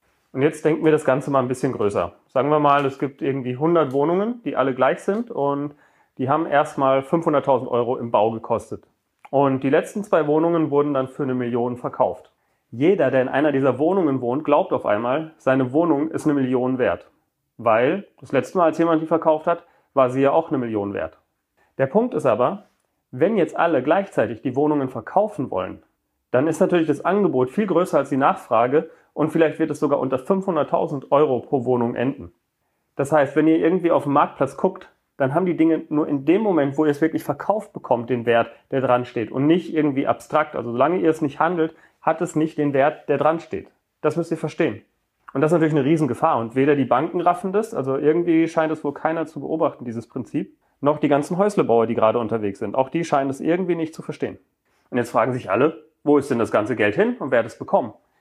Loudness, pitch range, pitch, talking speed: -21 LUFS, 130-160 Hz, 150 Hz, 220 wpm